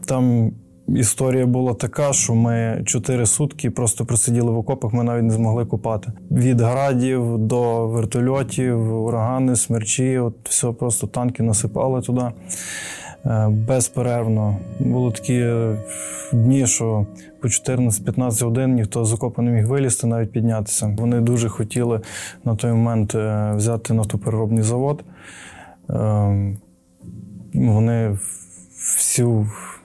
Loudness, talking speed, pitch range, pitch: -20 LUFS, 115 wpm, 110-125 Hz, 115 Hz